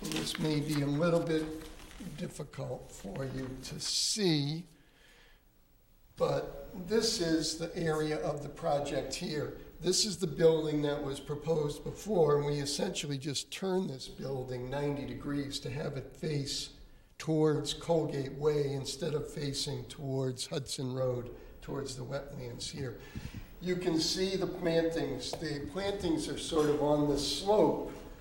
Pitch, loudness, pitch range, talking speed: 150 Hz, -33 LUFS, 140-165 Hz, 145 wpm